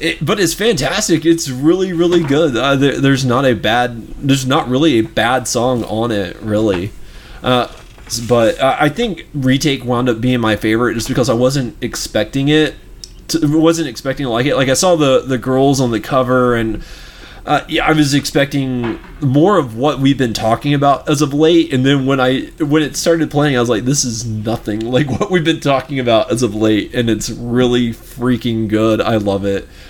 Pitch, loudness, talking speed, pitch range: 130 Hz, -14 LUFS, 205 wpm, 120-150 Hz